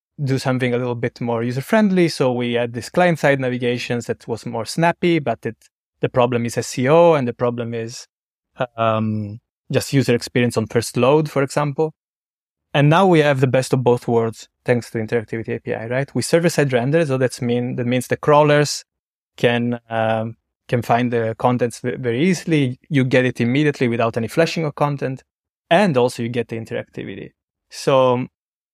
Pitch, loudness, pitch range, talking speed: 125 Hz, -19 LUFS, 120-145 Hz, 185 wpm